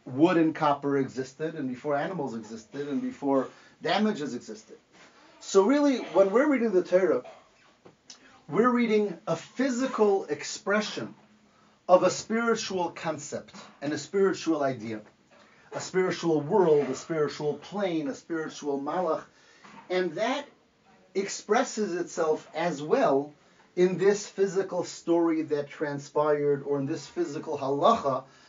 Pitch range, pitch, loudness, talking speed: 145-205 Hz, 170 Hz, -27 LUFS, 120 wpm